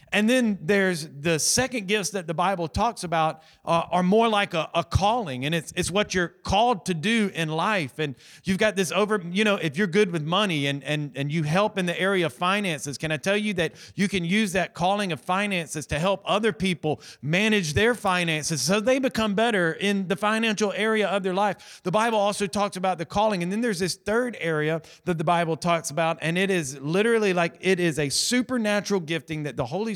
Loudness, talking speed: -24 LUFS, 220 wpm